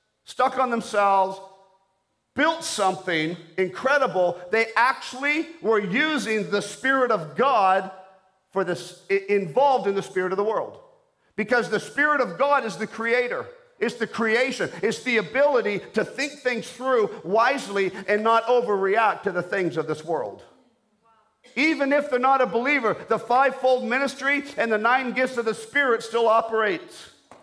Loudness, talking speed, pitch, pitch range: -23 LUFS, 150 wpm, 230 Hz, 195-265 Hz